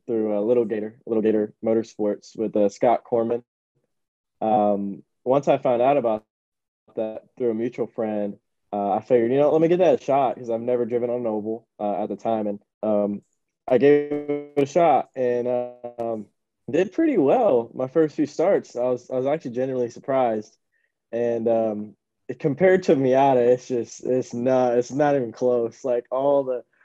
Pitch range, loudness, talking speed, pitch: 110-130 Hz, -23 LUFS, 185 wpm, 120 Hz